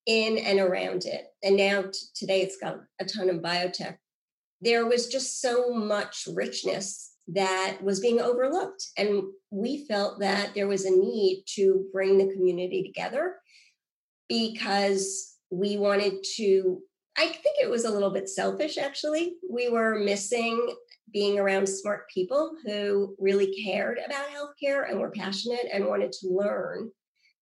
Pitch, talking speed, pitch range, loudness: 200 Hz, 150 wpm, 195-245 Hz, -27 LUFS